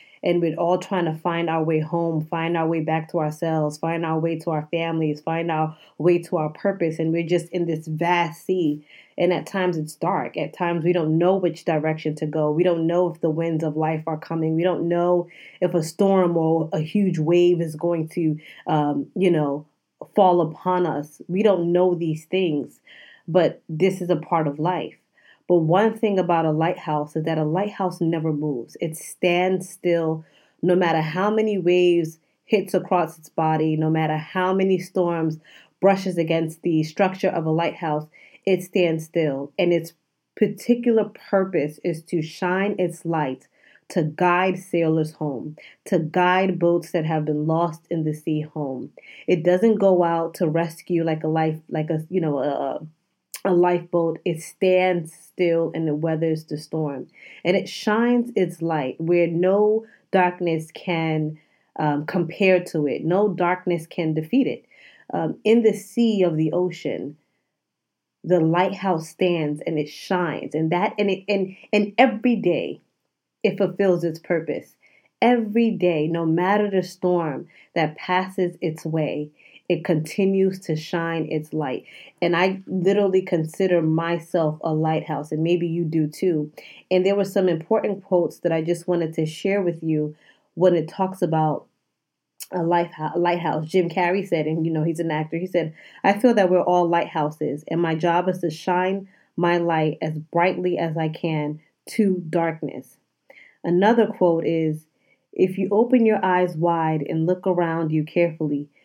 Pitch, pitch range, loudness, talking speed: 170 Hz, 160-185 Hz, -22 LUFS, 175 wpm